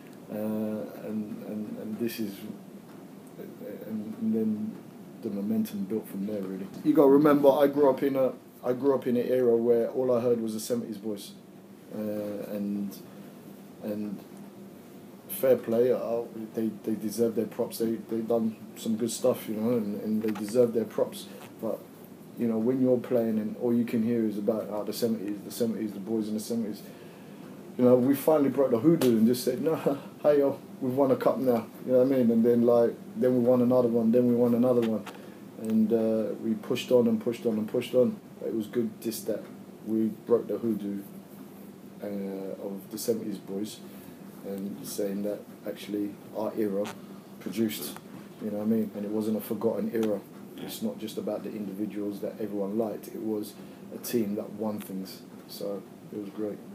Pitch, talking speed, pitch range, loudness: 115 Hz, 195 wpm, 105-125 Hz, -28 LUFS